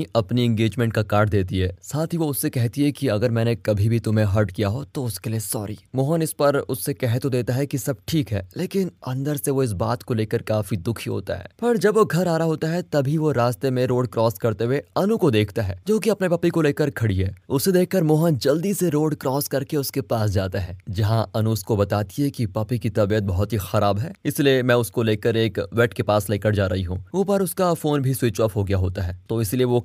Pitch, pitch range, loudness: 120 Hz, 110-145 Hz, -22 LUFS